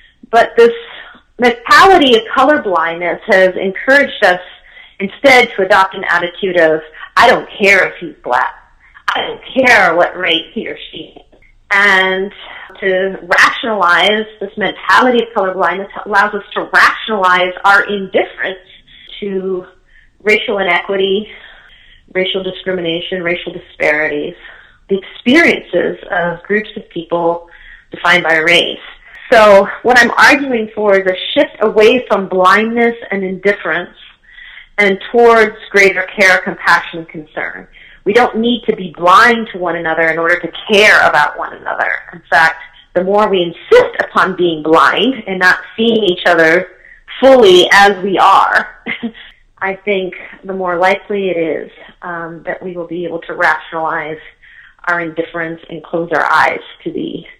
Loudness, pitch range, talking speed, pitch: -11 LUFS, 175-220 Hz, 140 wpm, 190 Hz